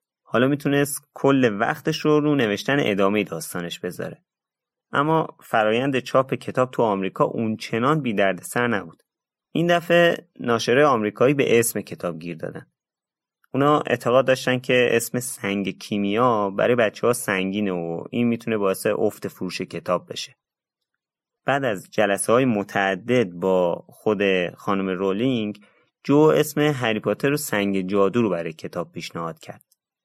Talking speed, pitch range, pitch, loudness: 140 wpm, 95-130 Hz, 110 Hz, -22 LUFS